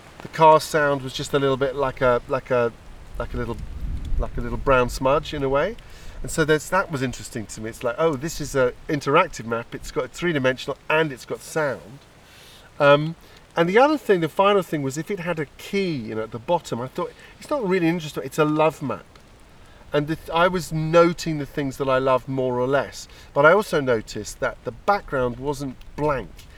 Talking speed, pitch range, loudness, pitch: 220 wpm, 125-160 Hz, -22 LUFS, 140 Hz